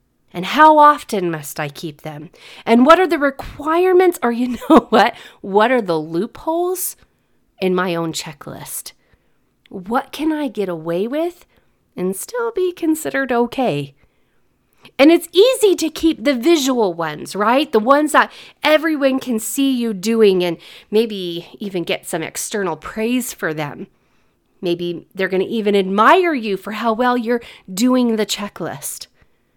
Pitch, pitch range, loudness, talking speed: 230 Hz, 185-295 Hz, -17 LUFS, 150 wpm